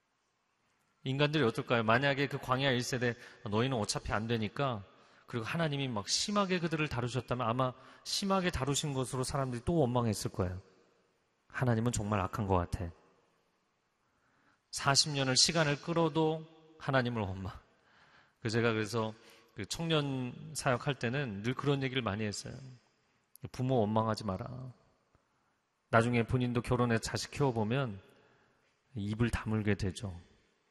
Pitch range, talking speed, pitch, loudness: 110-140 Hz, 290 characters per minute, 125 Hz, -33 LUFS